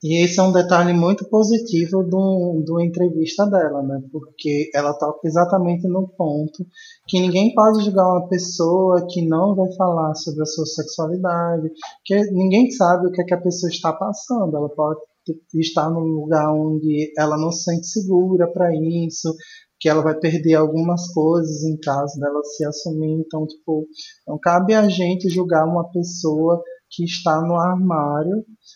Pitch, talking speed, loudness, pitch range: 170 Hz, 165 wpm, -19 LUFS, 155-185 Hz